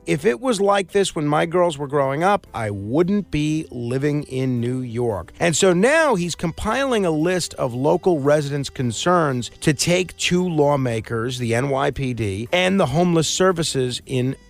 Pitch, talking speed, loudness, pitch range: 150 Hz, 165 wpm, -20 LUFS, 130-180 Hz